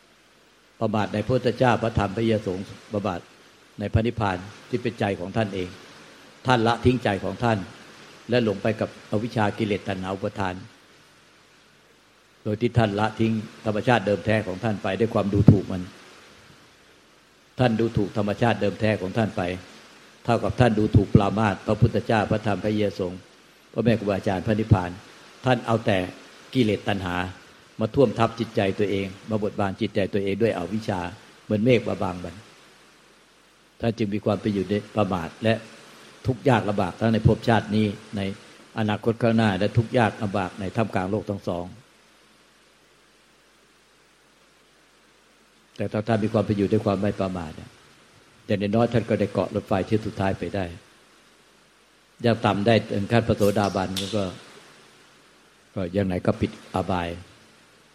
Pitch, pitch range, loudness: 105 Hz, 95-115 Hz, -24 LUFS